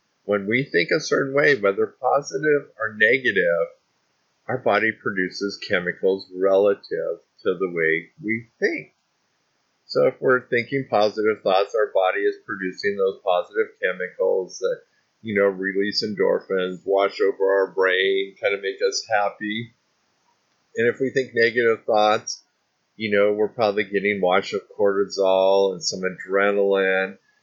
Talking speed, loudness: 140 wpm, -22 LUFS